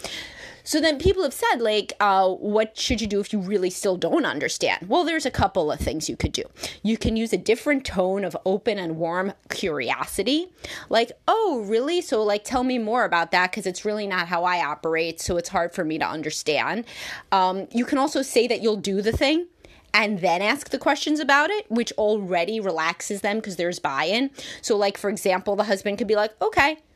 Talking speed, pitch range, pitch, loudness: 210 wpm, 185-250 Hz, 210 Hz, -23 LUFS